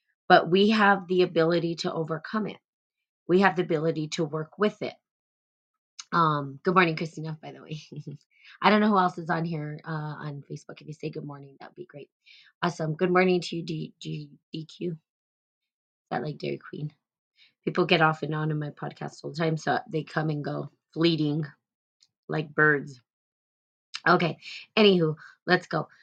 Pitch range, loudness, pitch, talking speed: 150-180 Hz, -26 LUFS, 160 Hz, 180 wpm